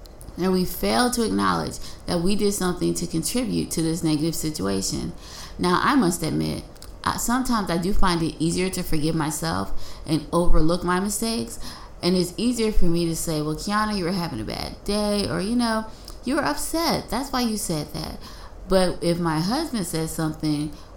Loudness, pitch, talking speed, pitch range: -24 LUFS, 175 Hz, 185 wpm, 160-210 Hz